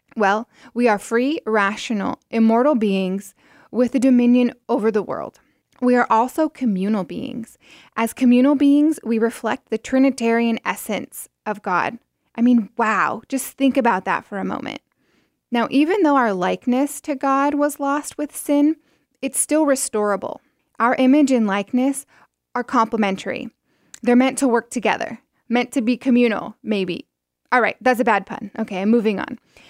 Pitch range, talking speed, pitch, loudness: 220-270 Hz, 160 wpm, 245 Hz, -19 LUFS